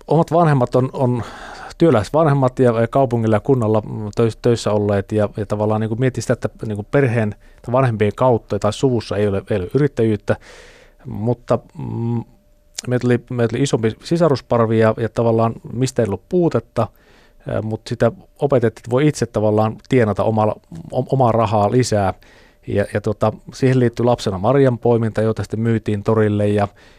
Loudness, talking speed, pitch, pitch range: -18 LUFS, 155 wpm, 115 Hz, 110-130 Hz